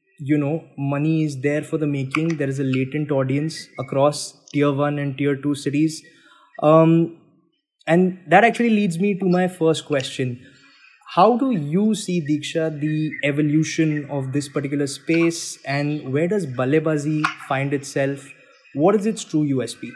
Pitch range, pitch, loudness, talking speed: 140-165 Hz, 150 Hz, -21 LUFS, 155 wpm